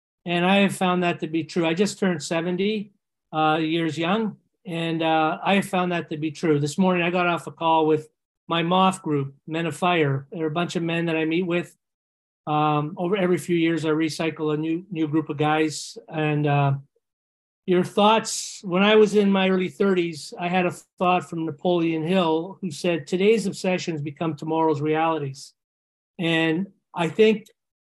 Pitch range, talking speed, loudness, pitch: 155-185 Hz, 190 wpm, -23 LUFS, 165 Hz